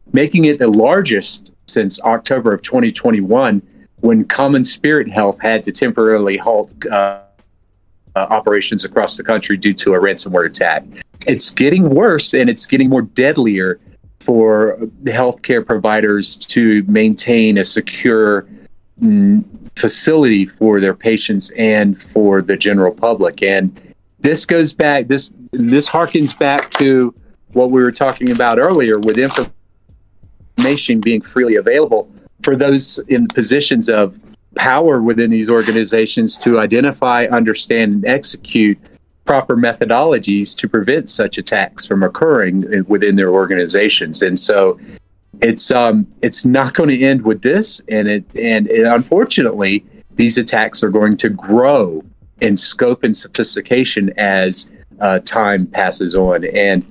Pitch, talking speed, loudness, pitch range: 110 Hz, 140 wpm, -13 LUFS, 100-135 Hz